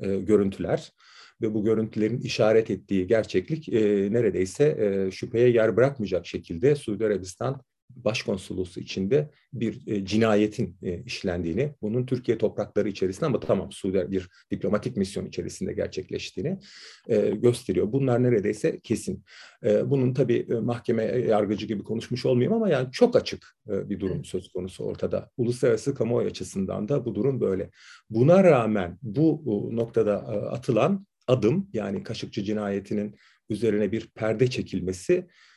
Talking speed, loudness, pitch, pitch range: 125 wpm, -26 LUFS, 110 Hz, 100-125 Hz